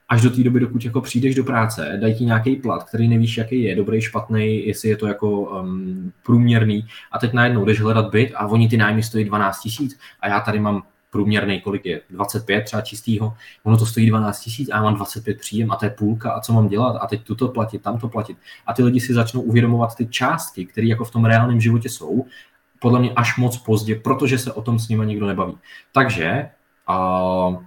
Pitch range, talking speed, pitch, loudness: 105-120 Hz, 220 wpm, 110 Hz, -20 LUFS